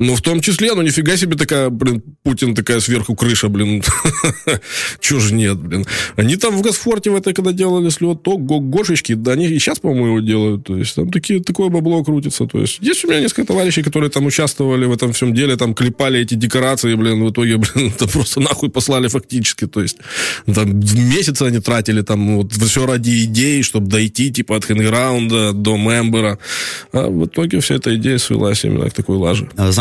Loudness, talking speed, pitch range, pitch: -15 LUFS, 200 wpm, 110-150 Hz, 125 Hz